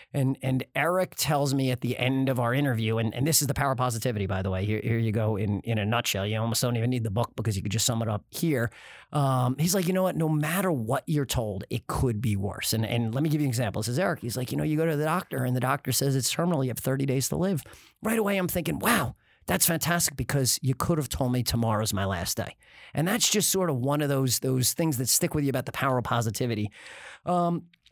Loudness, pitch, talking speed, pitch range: -27 LUFS, 130 Hz, 275 wpm, 115-155 Hz